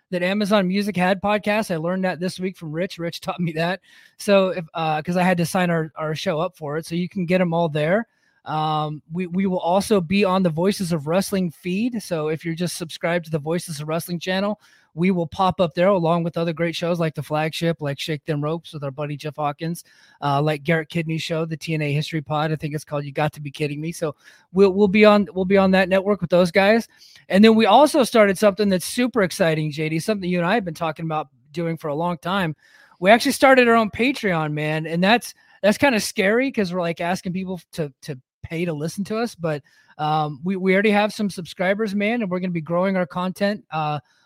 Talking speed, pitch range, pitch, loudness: 245 wpm, 160-195 Hz, 175 Hz, -21 LUFS